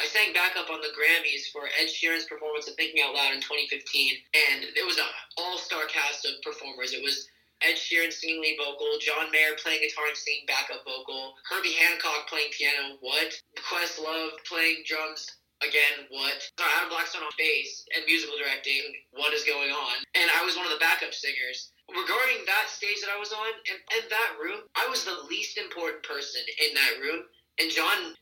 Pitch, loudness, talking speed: 165 Hz, -26 LUFS, 195 wpm